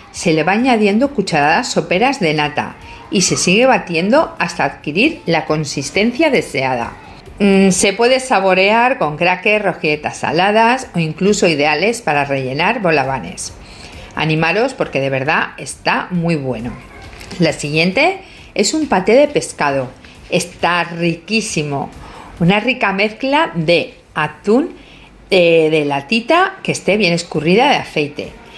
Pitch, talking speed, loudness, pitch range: 180 Hz, 130 wpm, -15 LUFS, 155-225 Hz